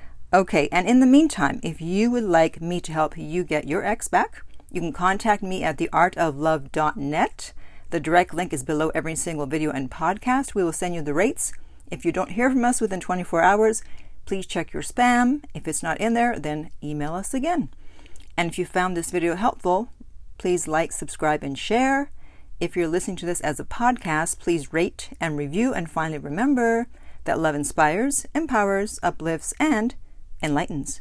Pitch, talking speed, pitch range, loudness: 175 Hz, 185 wpm, 155-215 Hz, -23 LUFS